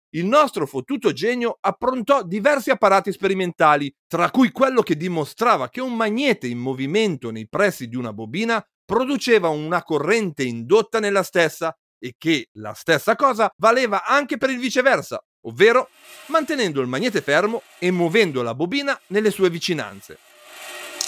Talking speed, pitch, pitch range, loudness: 145 wpm, 195 Hz, 160-245 Hz, -20 LUFS